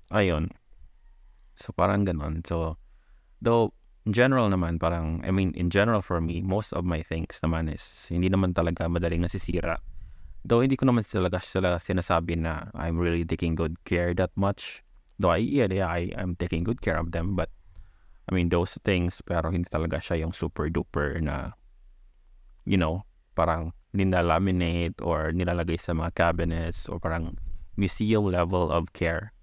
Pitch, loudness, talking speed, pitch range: 85 Hz, -27 LUFS, 170 wpm, 85-95 Hz